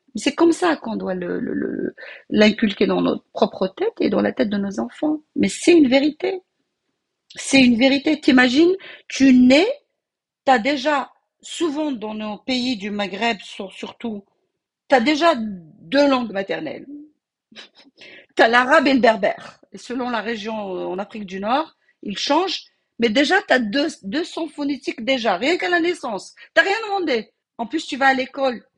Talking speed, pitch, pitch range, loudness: 170 wpm, 265 Hz, 225-305 Hz, -19 LUFS